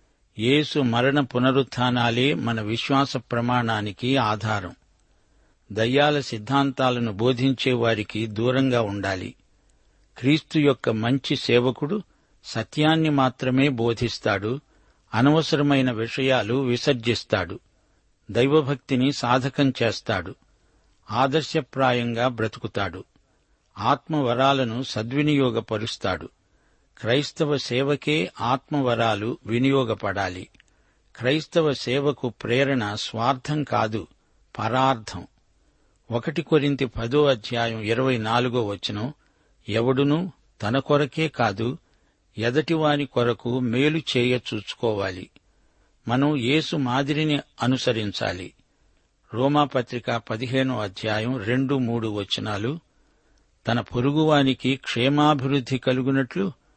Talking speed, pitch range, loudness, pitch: 75 wpm, 115-140 Hz, -23 LUFS, 125 Hz